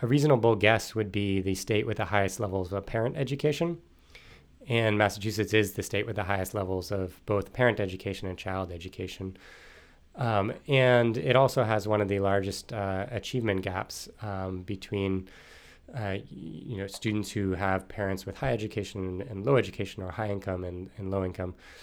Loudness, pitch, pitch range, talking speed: -29 LUFS, 100 Hz, 95-110 Hz, 175 wpm